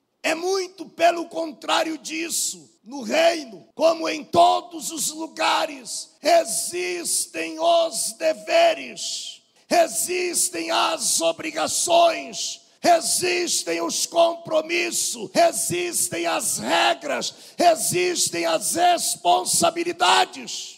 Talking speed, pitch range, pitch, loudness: 80 wpm, 295-340 Hz, 330 Hz, -21 LUFS